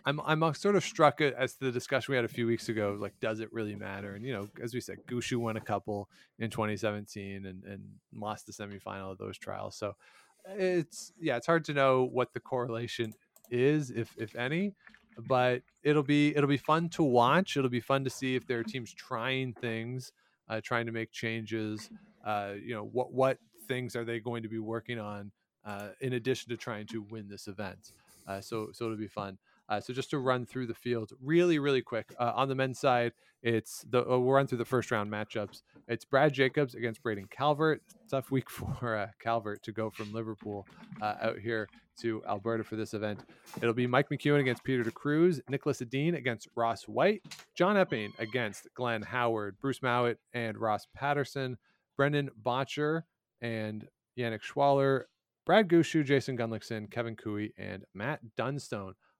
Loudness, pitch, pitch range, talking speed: -32 LUFS, 120 Hz, 110-135 Hz, 195 wpm